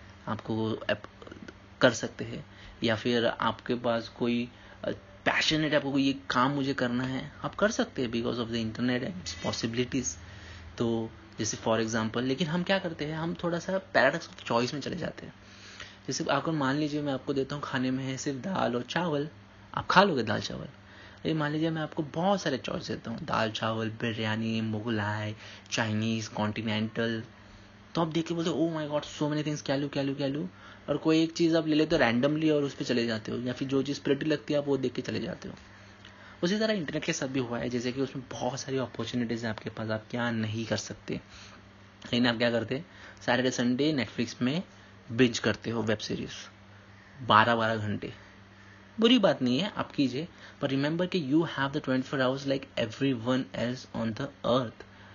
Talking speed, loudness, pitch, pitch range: 205 wpm, -30 LUFS, 125 Hz, 110-145 Hz